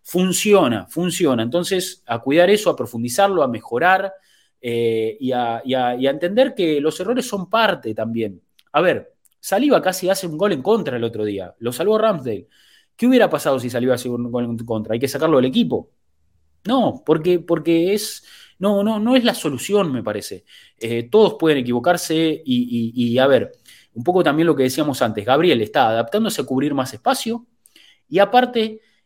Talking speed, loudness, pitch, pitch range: 190 wpm, -19 LUFS, 160 Hz, 120-205 Hz